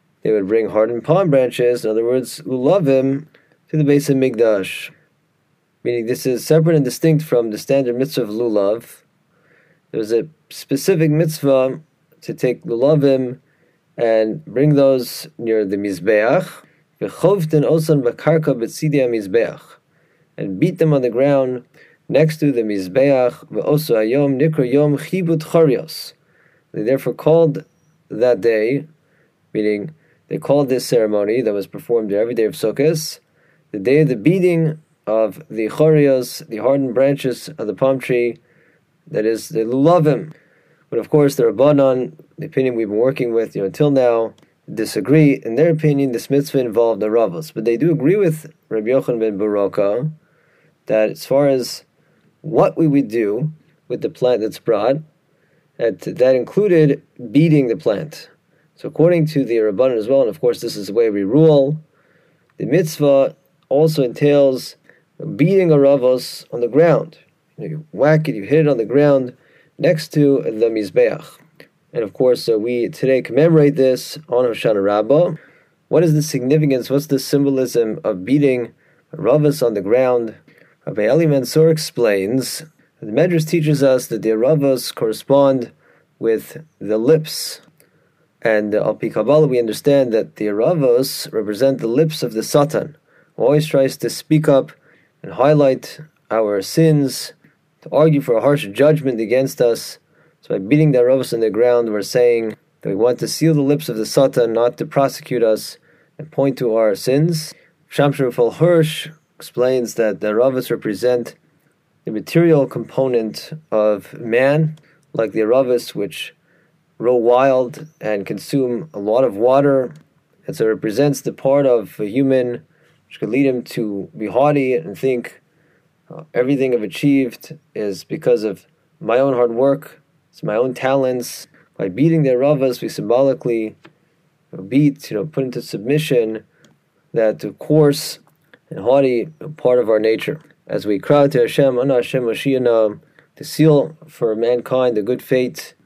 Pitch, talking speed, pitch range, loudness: 140 Hz, 155 wpm, 120-155 Hz, -17 LUFS